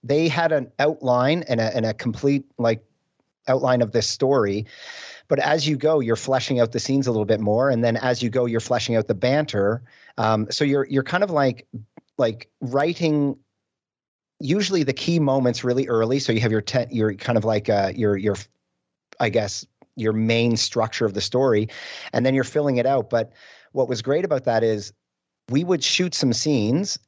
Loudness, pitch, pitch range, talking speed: -22 LUFS, 125 Hz, 110-140 Hz, 200 wpm